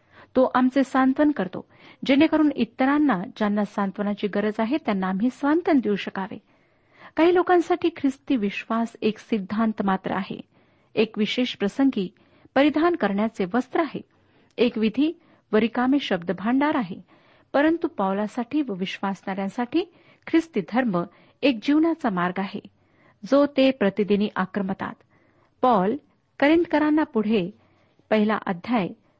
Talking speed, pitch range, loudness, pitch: 115 wpm, 205-285 Hz, -23 LUFS, 235 Hz